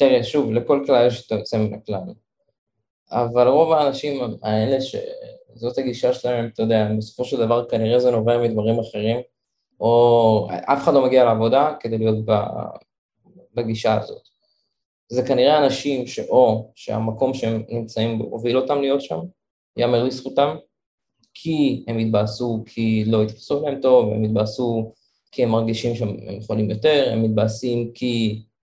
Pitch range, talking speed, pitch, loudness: 110-130 Hz, 145 wpm, 120 Hz, -20 LUFS